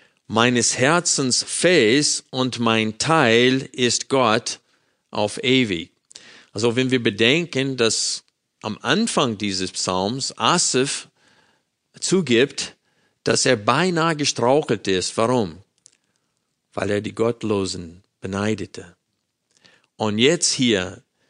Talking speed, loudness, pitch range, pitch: 100 wpm, -20 LUFS, 105-130 Hz, 120 Hz